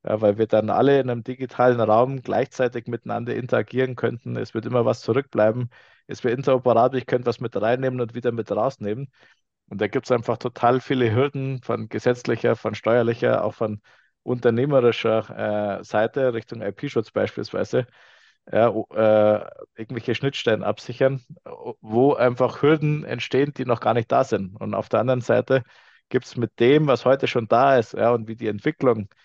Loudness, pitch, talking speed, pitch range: -22 LUFS, 120 Hz, 170 wpm, 110-130 Hz